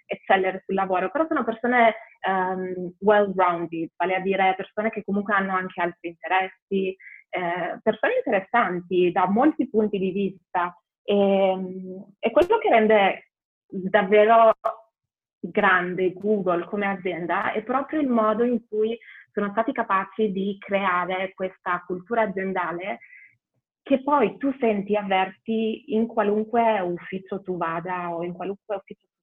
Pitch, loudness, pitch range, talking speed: 195 Hz, -23 LUFS, 185-220 Hz, 130 wpm